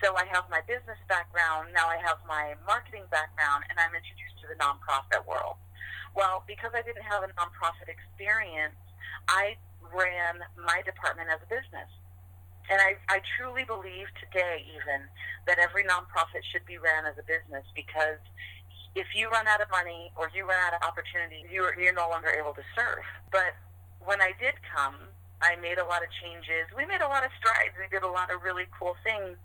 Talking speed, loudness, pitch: 195 wpm, -29 LUFS, 165 Hz